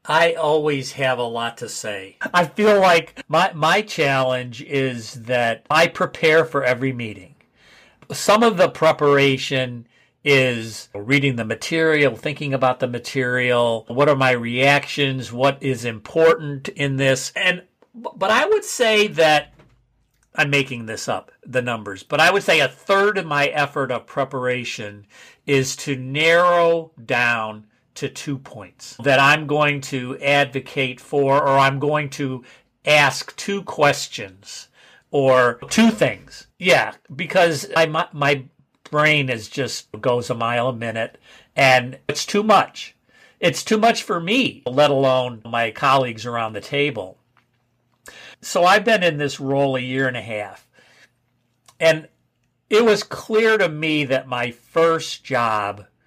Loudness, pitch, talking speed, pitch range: -19 LUFS, 135 Hz, 145 wpm, 125-160 Hz